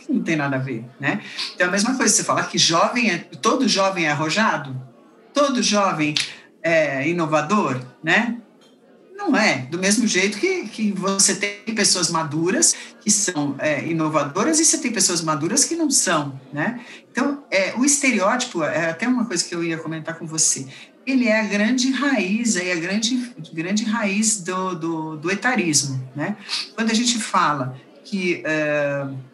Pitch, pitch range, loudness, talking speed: 195 Hz, 160-235 Hz, -20 LUFS, 175 wpm